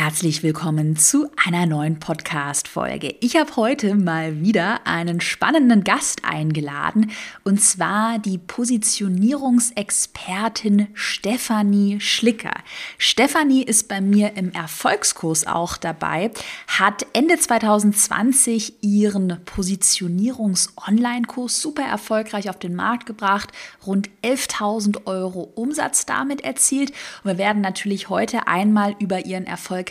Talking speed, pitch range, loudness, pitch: 110 wpm, 185-235 Hz, -19 LUFS, 205 Hz